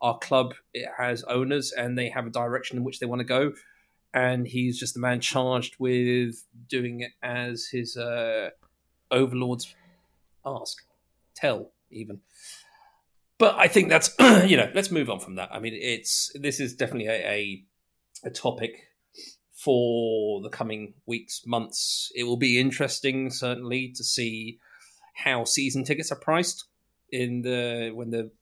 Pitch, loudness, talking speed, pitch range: 125 Hz, -25 LUFS, 155 wpm, 115-130 Hz